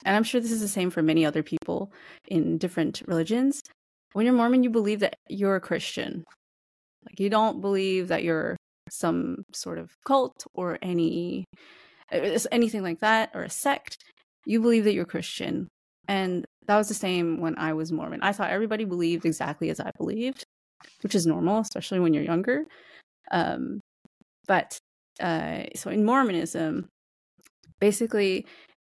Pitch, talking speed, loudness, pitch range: 195 Hz, 160 wpm, -26 LUFS, 170-225 Hz